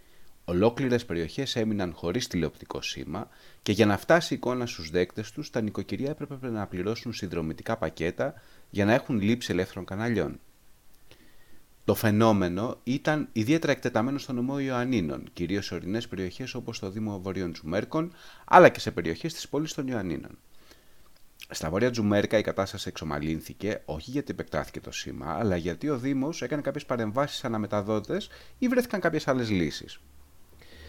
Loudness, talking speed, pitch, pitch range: -28 LUFS, 150 wpm, 110 Hz, 90-130 Hz